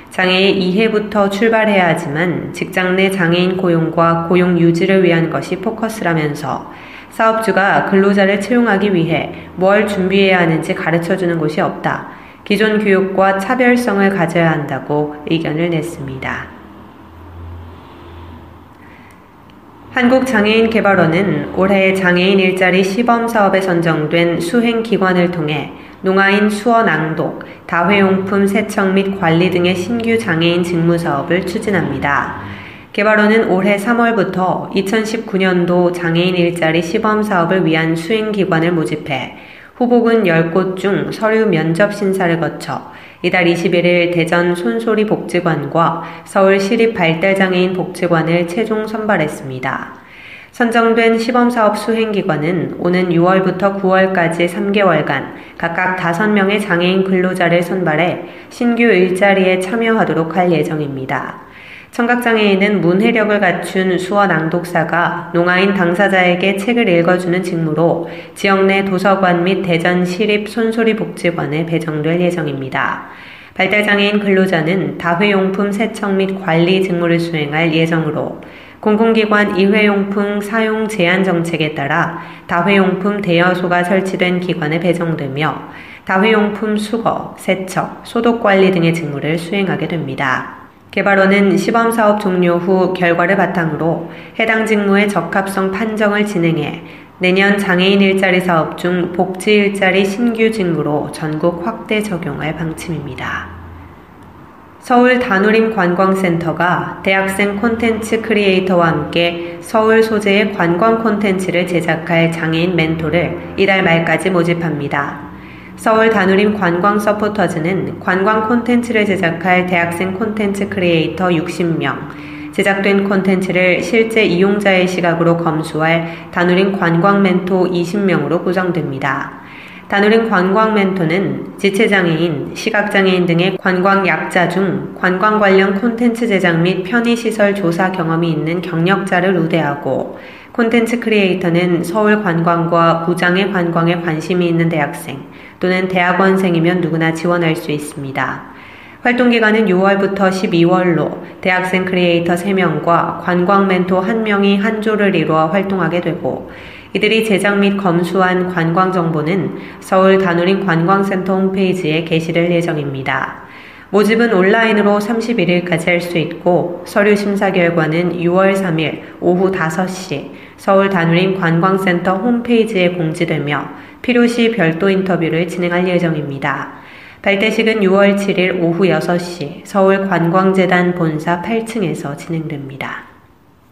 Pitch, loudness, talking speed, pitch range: 185 Hz, -14 LUFS, 290 characters per minute, 170-200 Hz